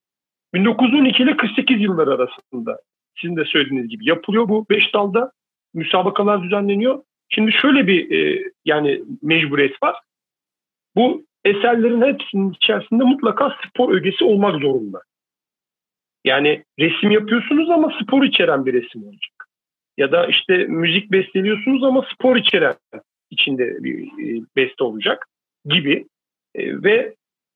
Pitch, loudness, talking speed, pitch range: 220 Hz, -17 LUFS, 115 wpm, 185-270 Hz